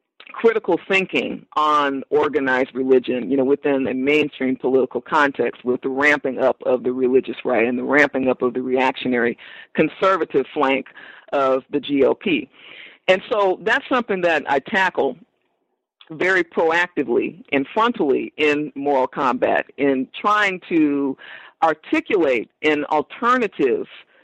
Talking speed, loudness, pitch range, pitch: 130 wpm, -19 LUFS, 130-195 Hz, 150 Hz